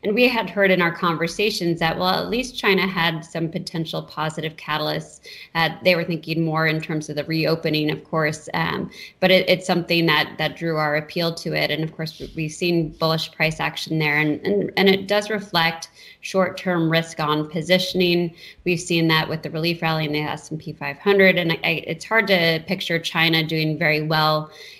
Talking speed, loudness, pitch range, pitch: 200 wpm, -21 LUFS, 155-180 Hz, 165 Hz